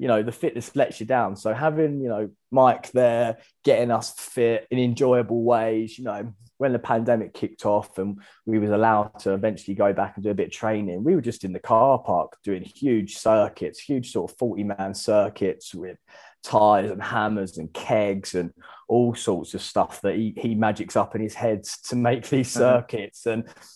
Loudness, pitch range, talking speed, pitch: -24 LUFS, 105-120 Hz, 200 wpm, 110 Hz